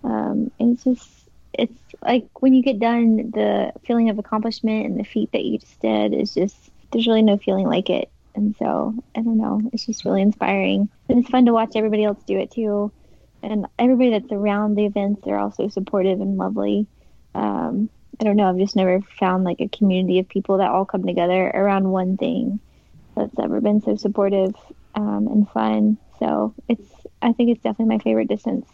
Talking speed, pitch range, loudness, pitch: 205 wpm, 190-230 Hz, -21 LUFS, 210 Hz